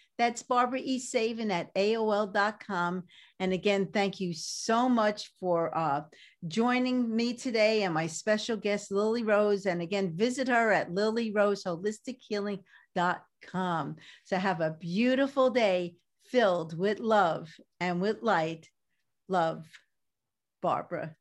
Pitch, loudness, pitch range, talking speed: 205 Hz, -29 LUFS, 175-225 Hz, 120 wpm